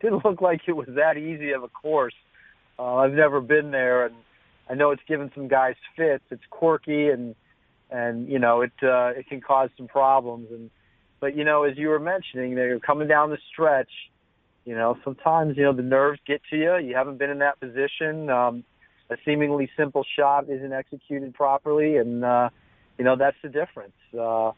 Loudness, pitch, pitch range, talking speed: -23 LUFS, 135 Hz, 125-150 Hz, 200 wpm